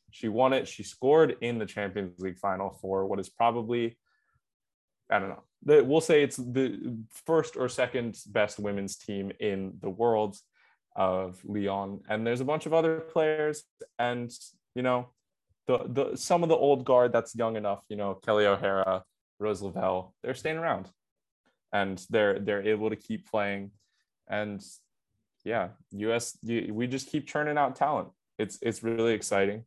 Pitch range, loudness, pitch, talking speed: 100-125 Hz, -29 LUFS, 110 Hz, 165 wpm